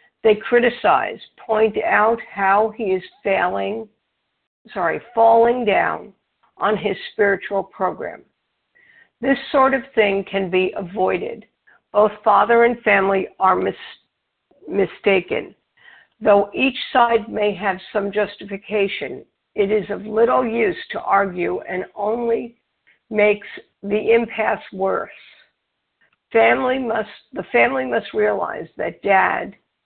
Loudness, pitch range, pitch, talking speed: -19 LUFS, 200-235 Hz, 215 Hz, 115 wpm